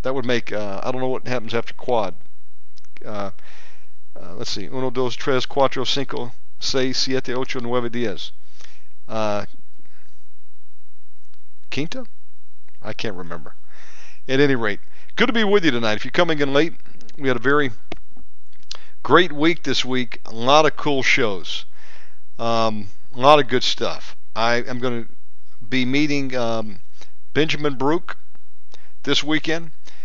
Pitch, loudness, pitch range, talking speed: 130 Hz, -21 LUFS, 115-145 Hz, 150 wpm